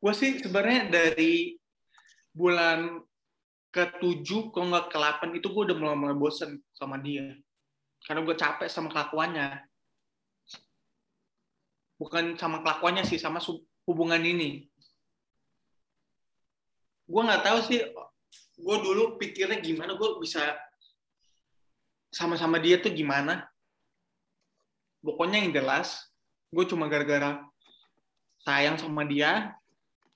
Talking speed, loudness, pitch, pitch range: 100 wpm, -28 LUFS, 170 Hz, 150-200 Hz